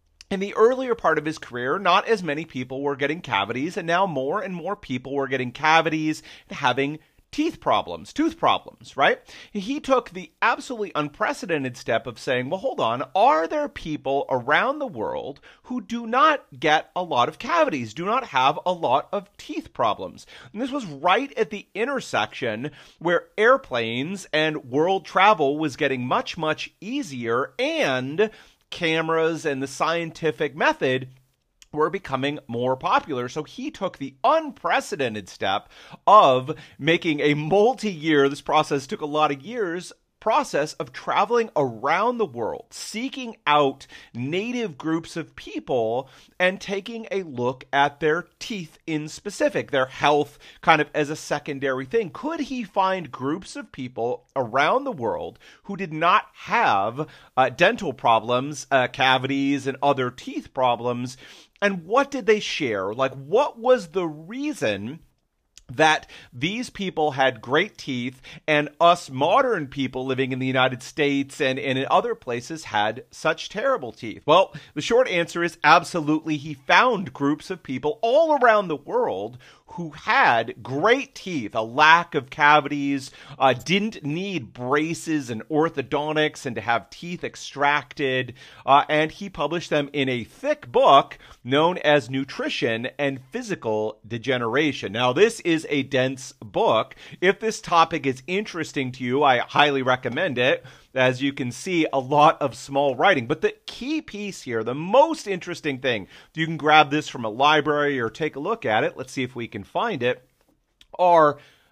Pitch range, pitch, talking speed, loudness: 135-195 Hz, 155 Hz, 160 wpm, -23 LUFS